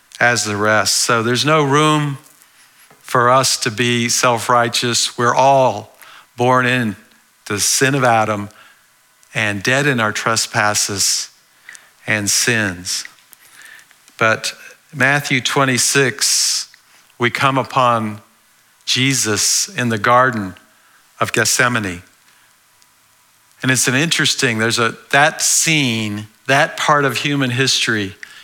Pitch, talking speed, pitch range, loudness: 120 Hz, 110 wpm, 110-130 Hz, -15 LUFS